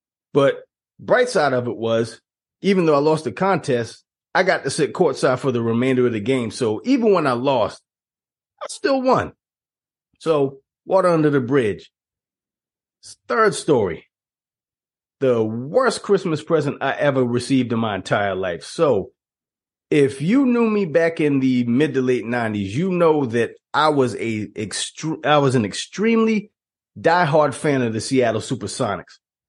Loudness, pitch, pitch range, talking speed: -20 LUFS, 140 Hz, 120-170 Hz, 160 wpm